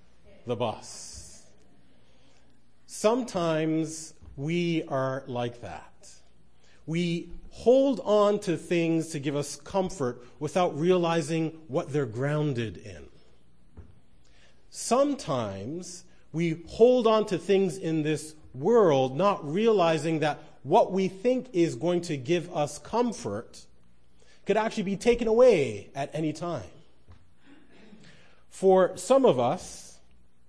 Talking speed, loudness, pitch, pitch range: 110 wpm, -26 LUFS, 160 Hz, 130-185 Hz